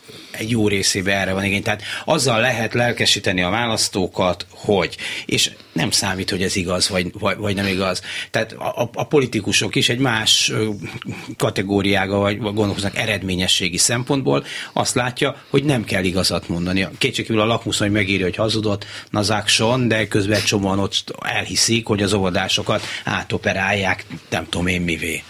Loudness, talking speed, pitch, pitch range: -19 LUFS, 150 wpm, 105 Hz, 95-115 Hz